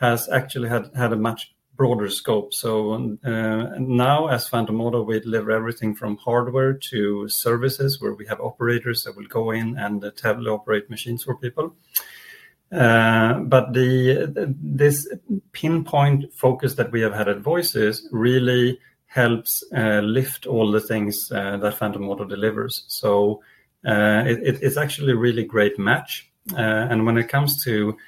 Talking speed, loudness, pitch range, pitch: 160 wpm, -21 LUFS, 110-130 Hz, 115 Hz